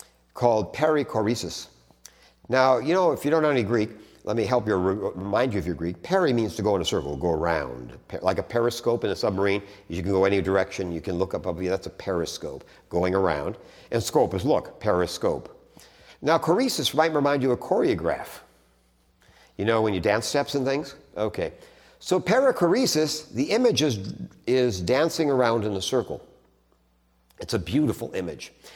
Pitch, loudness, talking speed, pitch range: 115 Hz, -25 LUFS, 180 wpm, 95-145 Hz